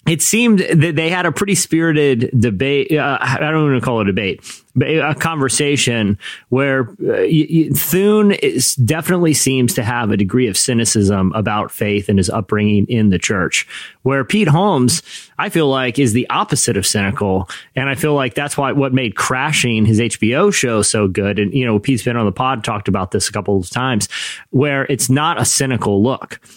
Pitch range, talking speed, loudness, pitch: 105-145 Hz, 200 wpm, -15 LUFS, 130 Hz